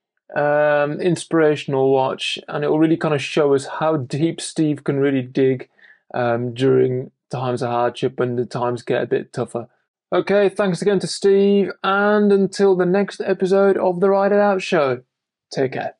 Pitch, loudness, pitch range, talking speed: 155 Hz, -19 LUFS, 135-195 Hz, 175 wpm